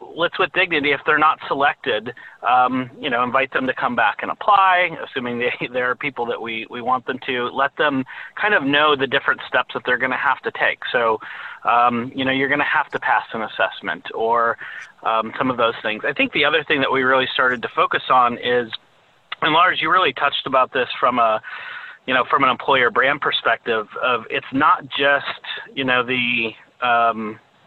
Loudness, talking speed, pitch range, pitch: -19 LUFS, 215 wpm, 120-140 Hz, 125 Hz